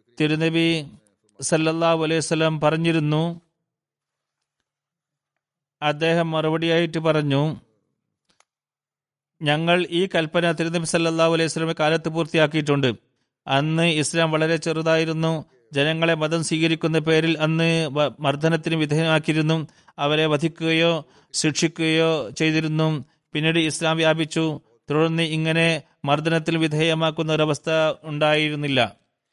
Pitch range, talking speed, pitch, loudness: 150-165 Hz, 80 wpm, 160 Hz, -21 LUFS